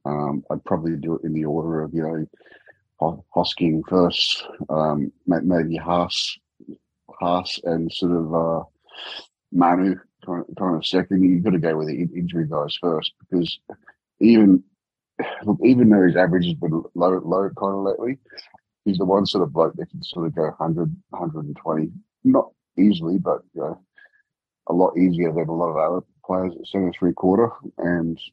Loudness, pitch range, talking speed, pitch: -21 LUFS, 80-95 Hz, 170 wpm, 85 Hz